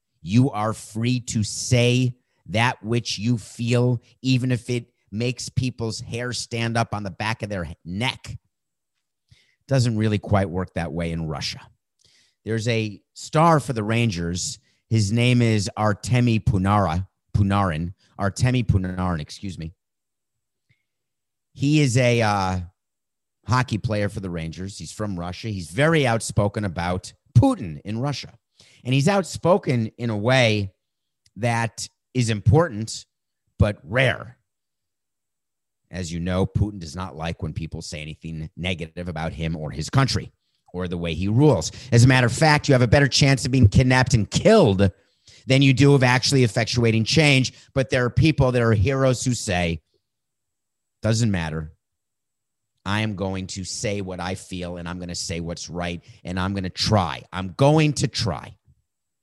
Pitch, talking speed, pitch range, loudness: 110 Hz, 160 wpm, 95-125 Hz, -22 LUFS